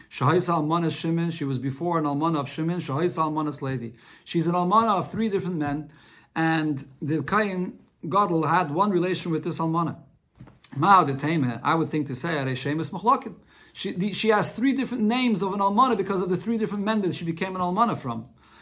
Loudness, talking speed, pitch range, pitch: -25 LUFS, 175 wpm, 150-195 Hz, 170 Hz